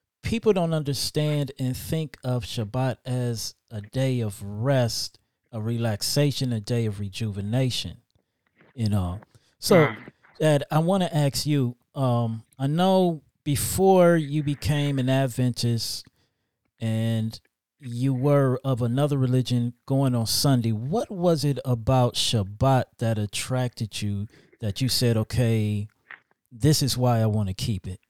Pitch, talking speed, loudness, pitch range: 125 Hz, 135 wpm, -25 LUFS, 115-140 Hz